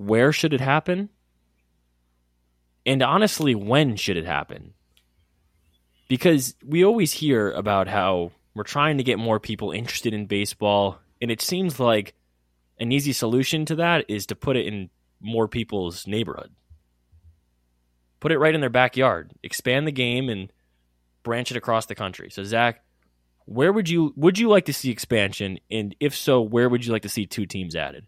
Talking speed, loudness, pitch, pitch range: 170 wpm, -23 LUFS, 110 Hz, 85-130 Hz